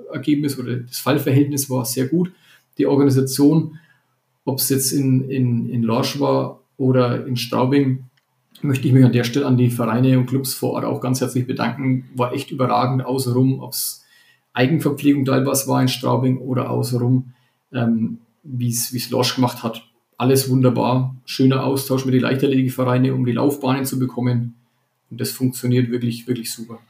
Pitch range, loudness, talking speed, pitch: 125-135 Hz, -19 LUFS, 175 wpm, 130 Hz